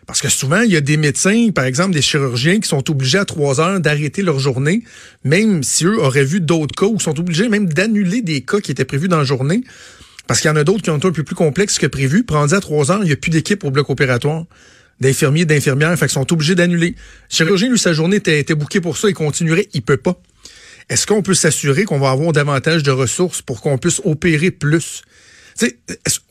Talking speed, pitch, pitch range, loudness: 245 wpm, 160 Hz, 145-190 Hz, -15 LUFS